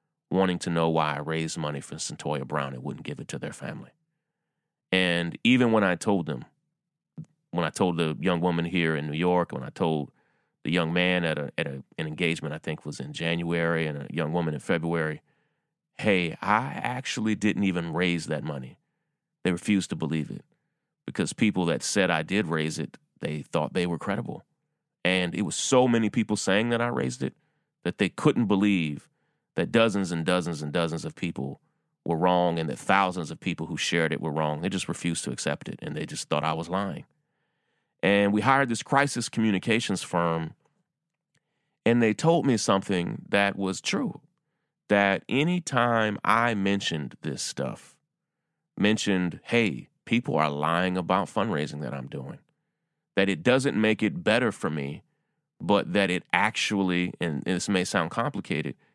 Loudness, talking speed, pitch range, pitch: -27 LUFS, 180 wpm, 80-115 Hz, 90 Hz